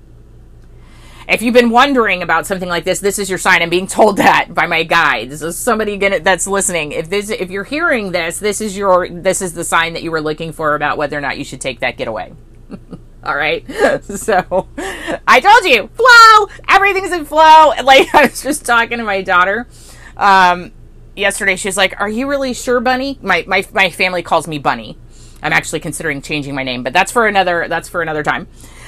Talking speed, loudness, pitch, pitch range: 210 wpm, -12 LUFS, 185 Hz, 165-230 Hz